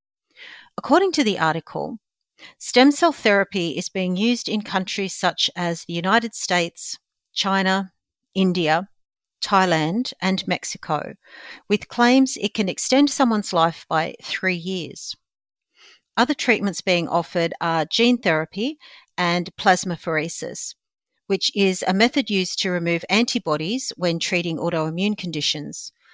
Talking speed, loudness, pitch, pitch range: 120 wpm, -21 LUFS, 190 Hz, 170-230 Hz